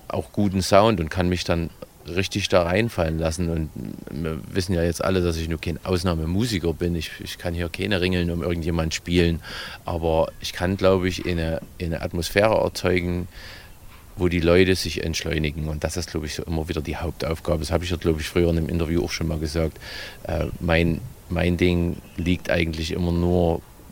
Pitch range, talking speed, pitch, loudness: 80-90 Hz, 195 wpm, 85 Hz, -24 LUFS